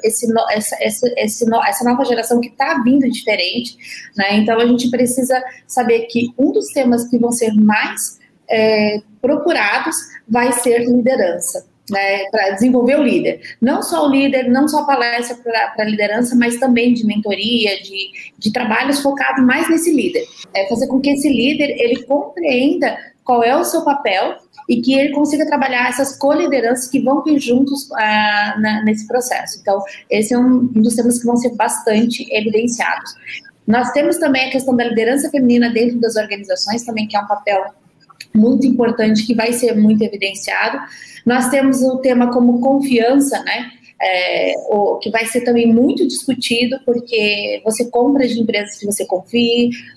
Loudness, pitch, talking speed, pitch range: -15 LUFS, 240 Hz, 170 wpm, 220-265 Hz